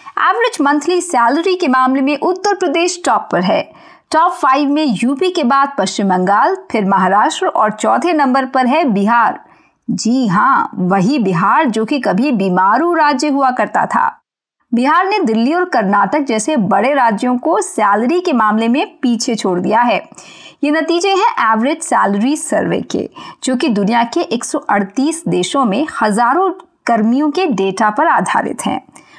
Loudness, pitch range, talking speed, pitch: -14 LUFS, 220-320 Hz, 160 wpm, 270 Hz